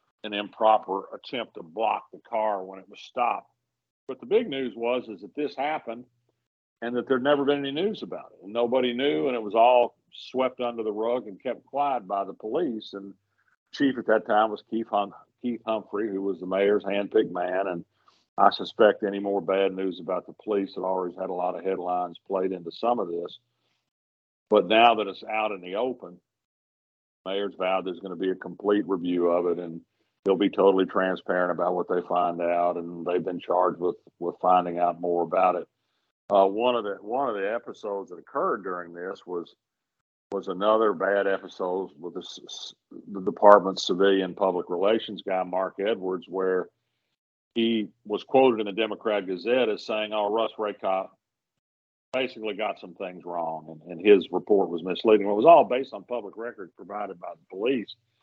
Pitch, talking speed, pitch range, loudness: 100 Hz, 195 wpm, 90-110 Hz, -26 LUFS